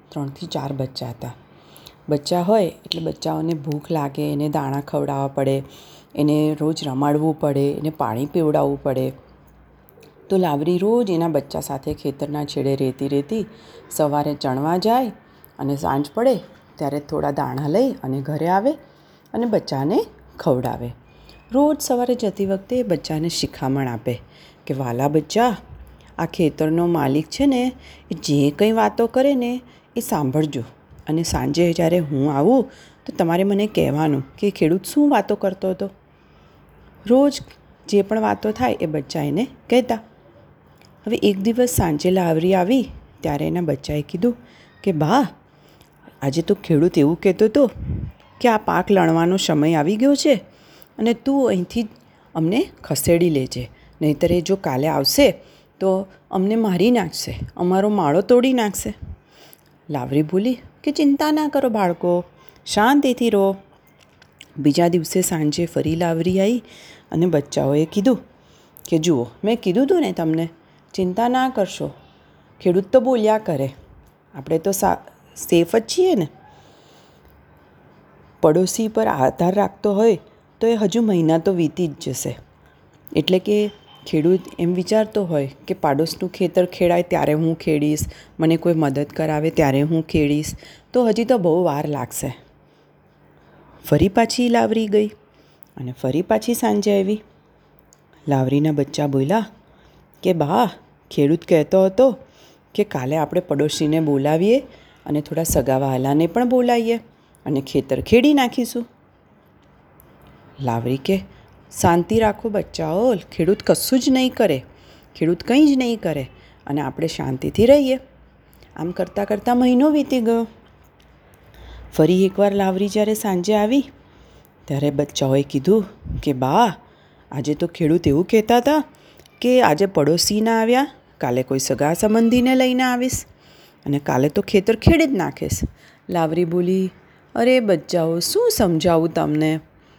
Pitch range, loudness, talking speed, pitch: 145-215 Hz, -19 LUFS, 135 wpm, 170 Hz